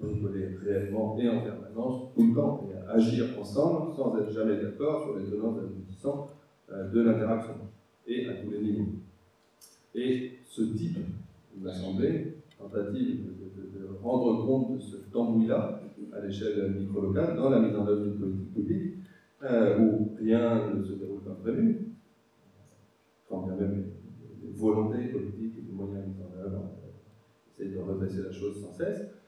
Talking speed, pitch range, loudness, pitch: 160 wpm, 100-120 Hz, -30 LUFS, 105 Hz